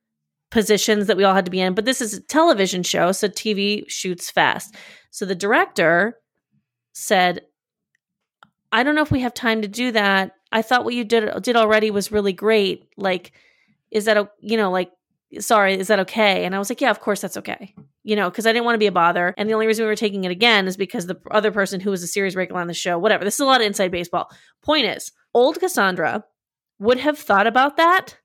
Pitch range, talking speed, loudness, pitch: 185-225 Hz, 235 wpm, -19 LUFS, 205 Hz